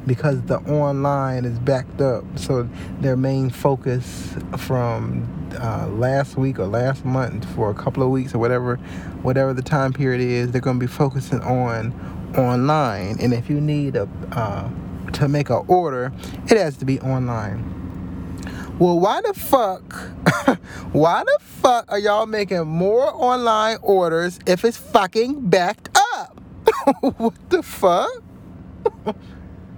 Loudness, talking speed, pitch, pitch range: -20 LUFS, 145 wpm, 135 Hz, 120-175 Hz